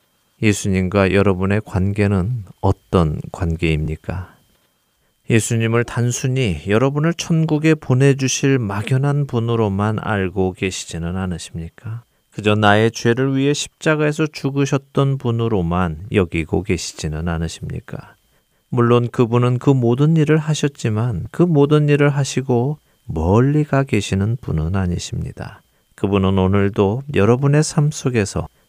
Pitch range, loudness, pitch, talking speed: 95-140 Hz, -18 LUFS, 115 Hz, 285 characters per minute